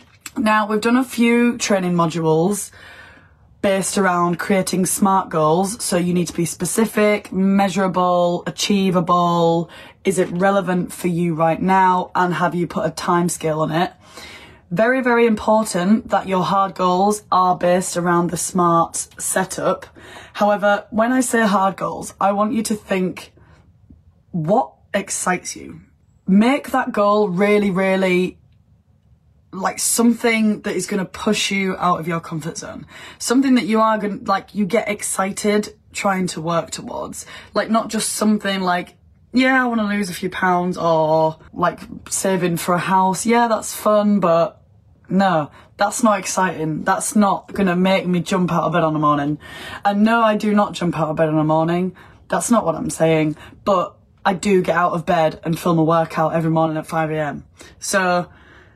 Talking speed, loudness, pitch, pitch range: 170 wpm, -18 LUFS, 185 Hz, 170-210 Hz